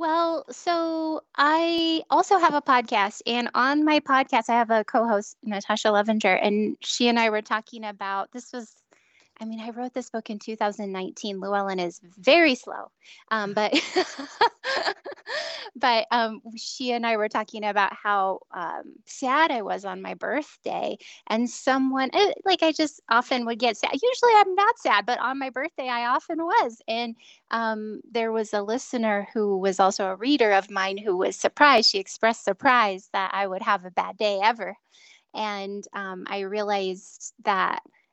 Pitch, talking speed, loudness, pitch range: 230 Hz, 170 wpm, -24 LUFS, 205-285 Hz